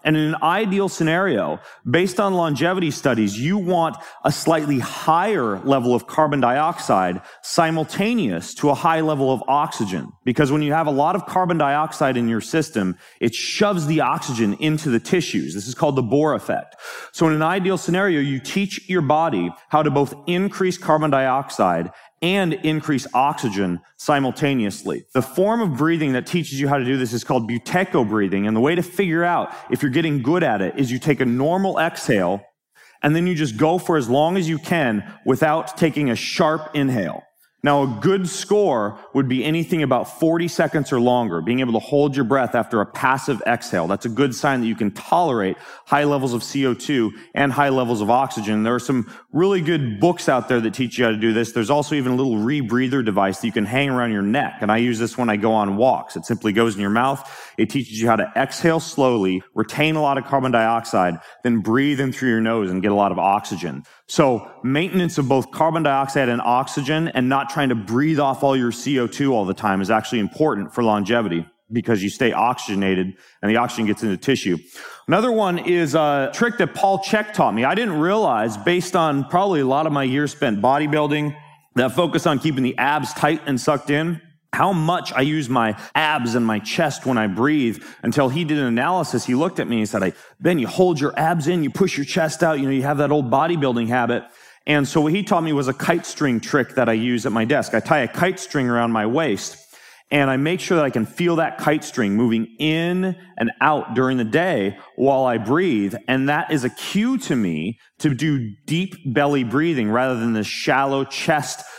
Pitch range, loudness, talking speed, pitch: 120-160 Hz, -20 LUFS, 215 wpm, 140 Hz